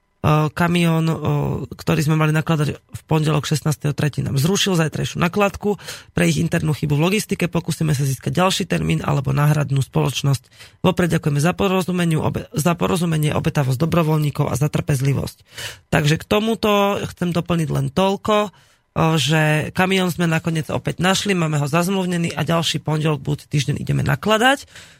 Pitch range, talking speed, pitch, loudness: 150-175 Hz, 140 wpm, 160 Hz, -19 LUFS